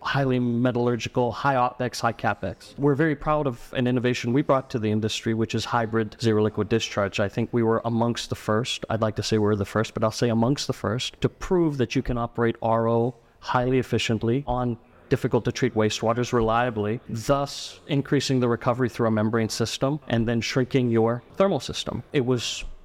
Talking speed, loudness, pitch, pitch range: 195 wpm, -25 LUFS, 120 Hz, 115-130 Hz